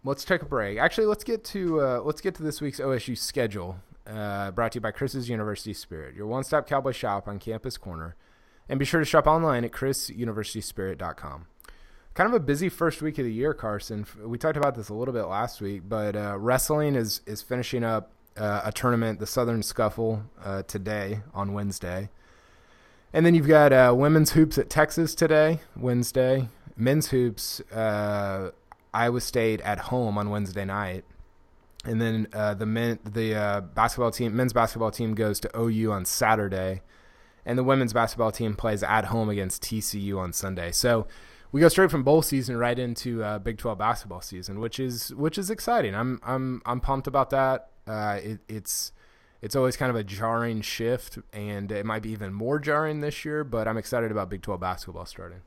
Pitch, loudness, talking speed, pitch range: 115 Hz, -26 LUFS, 190 wpm, 105-130 Hz